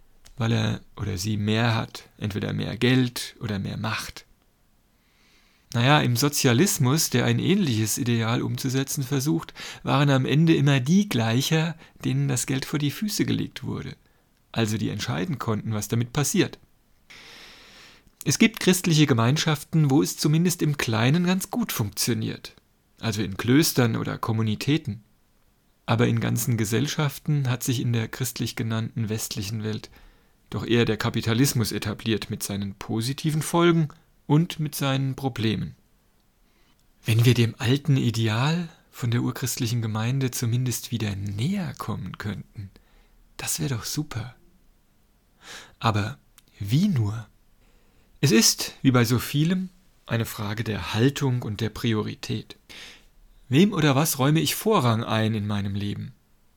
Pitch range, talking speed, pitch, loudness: 110-145 Hz, 135 wpm, 125 Hz, -24 LUFS